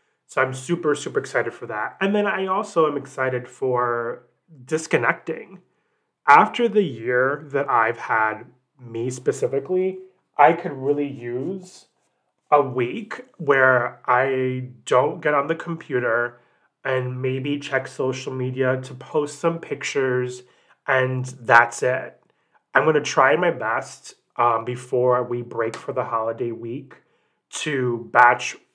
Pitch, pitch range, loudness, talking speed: 130 Hz, 125-150 Hz, -22 LUFS, 130 wpm